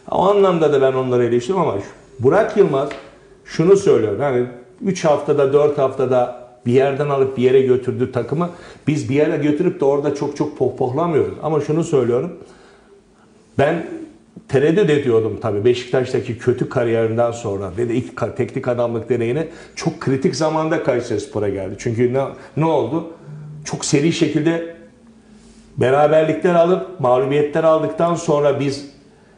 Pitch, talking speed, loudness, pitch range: 145 Hz, 135 wpm, -18 LUFS, 125-165 Hz